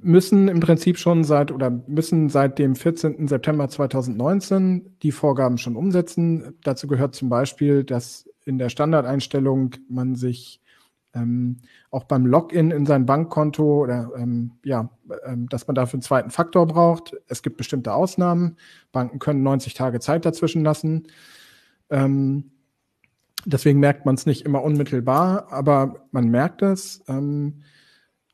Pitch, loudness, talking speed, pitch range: 140 Hz, -21 LUFS, 140 wpm, 130-160 Hz